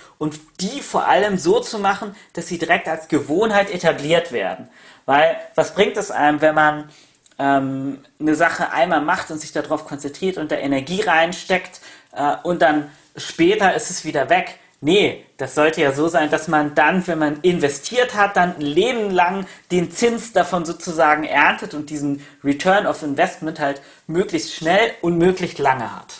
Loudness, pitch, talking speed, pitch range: -19 LUFS, 160 Hz, 175 wpm, 150-185 Hz